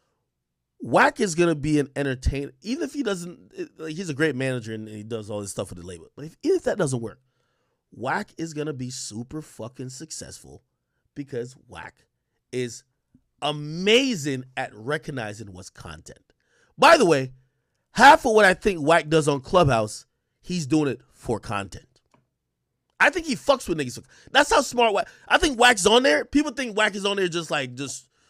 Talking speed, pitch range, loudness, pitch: 190 wpm, 125-195 Hz, -22 LUFS, 150 Hz